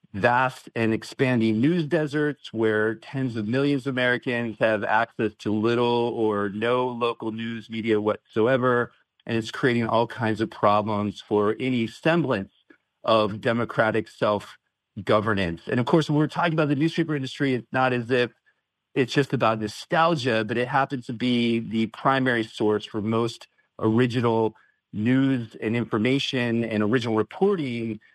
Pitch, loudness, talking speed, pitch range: 115 Hz, -24 LUFS, 150 wpm, 110-130 Hz